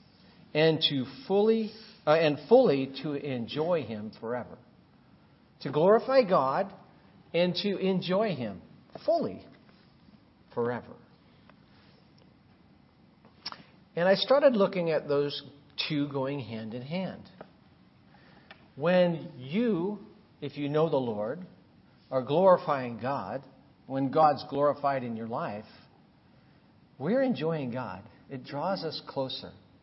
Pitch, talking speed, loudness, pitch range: 150 Hz, 105 wpm, -28 LUFS, 135-190 Hz